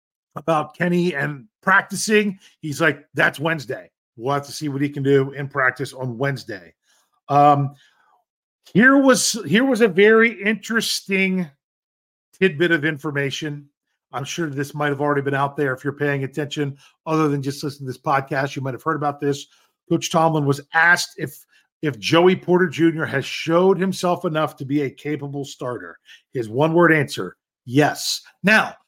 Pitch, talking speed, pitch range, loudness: 150 Hz, 170 wpm, 140-175 Hz, -20 LUFS